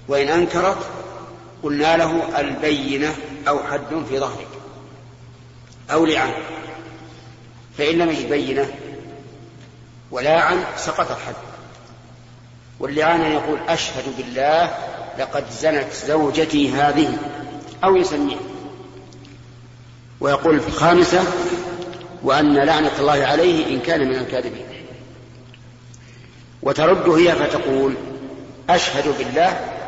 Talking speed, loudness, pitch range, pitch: 90 wpm, -19 LUFS, 125-160 Hz, 140 Hz